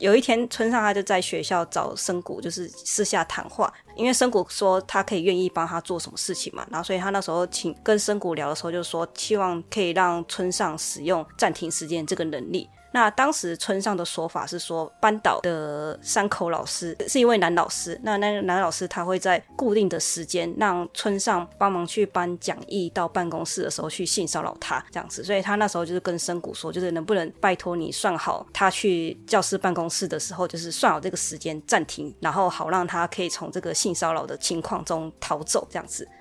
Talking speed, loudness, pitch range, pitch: 325 characters per minute, -25 LUFS, 170-200 Hz, 180 Hz